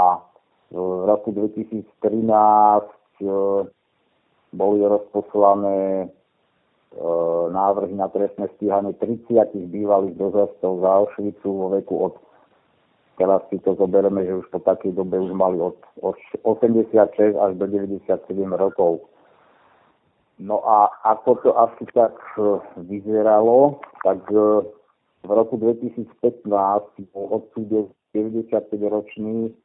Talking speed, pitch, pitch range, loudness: 105 wpm, 100 Hz, 95-105 Hz, -20 LUFS